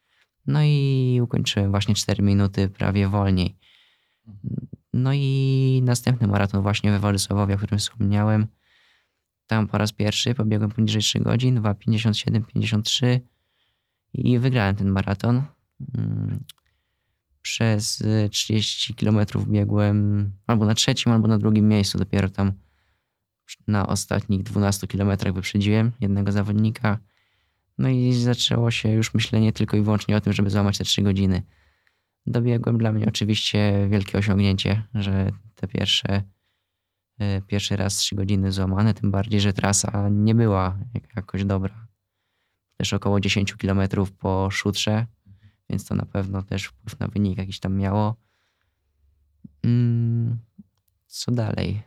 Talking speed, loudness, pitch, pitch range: 125 wpm, -22 LUFS, 105 Hz, 100-110 Hz